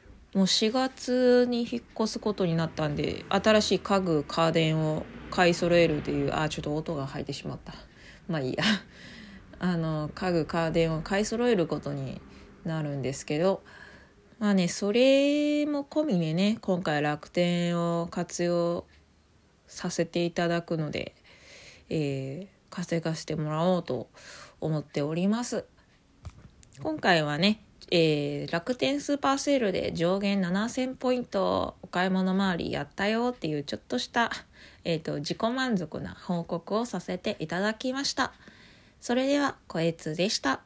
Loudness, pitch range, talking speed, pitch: -28 LUFS, 155-215 Hz, 280 characters per minute, 175 Hz